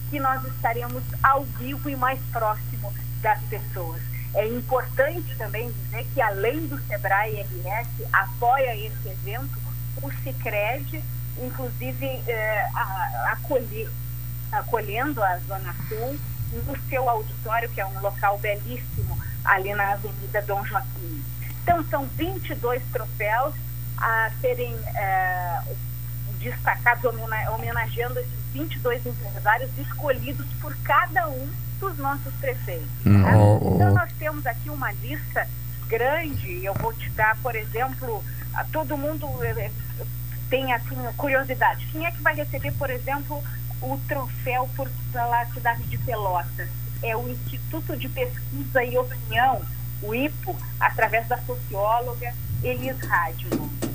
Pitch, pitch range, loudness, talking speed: 120 Hz, 120-130 Hz, -26 LUFS, 130 wpm